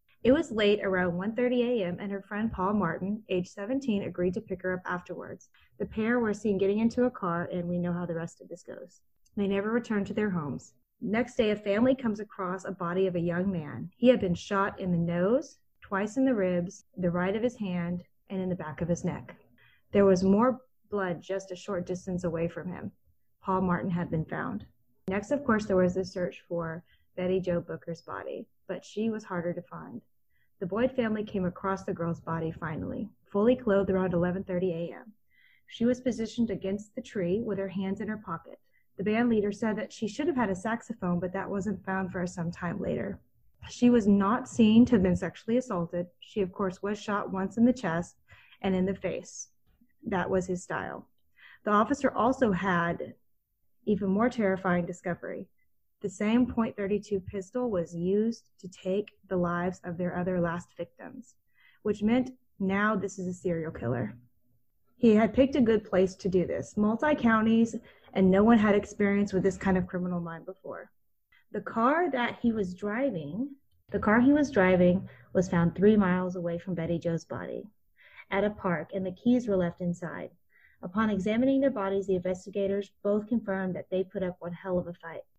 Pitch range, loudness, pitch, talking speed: 180-220 Hz, -29 LUFS, 195 Hz, 200 wpm